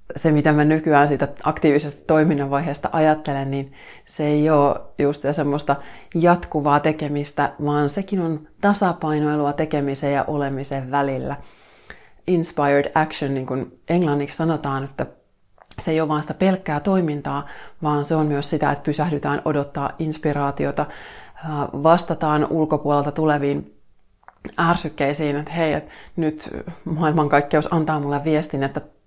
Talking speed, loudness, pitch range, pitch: 125 wpm, -21 LUFS, 145-155 Hz, 150 Hz